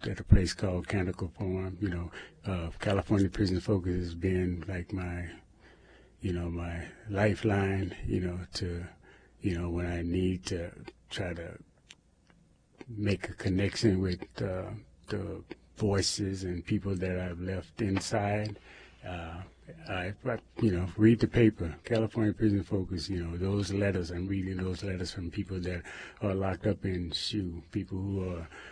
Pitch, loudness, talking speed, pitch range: 95 Hz, -32 LUFS, 155 wpm, 90-100 Hz